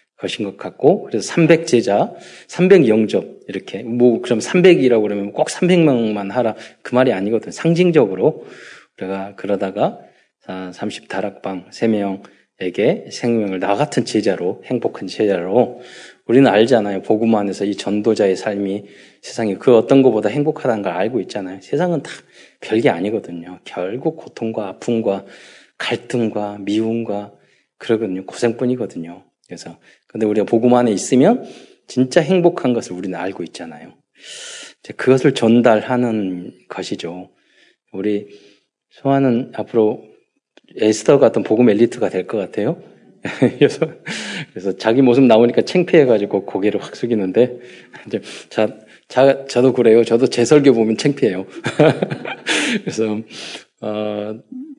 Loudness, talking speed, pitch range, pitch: -17 LUFS, 290 characters per minute, 100-125 Hz, 110 Hz